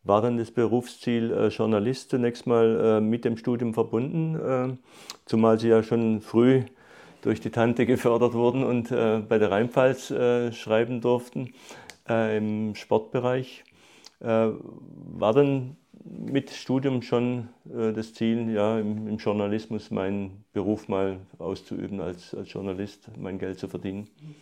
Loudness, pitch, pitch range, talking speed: -26 LUFS, 115 Hz, 110-125 Hz, 145 wpm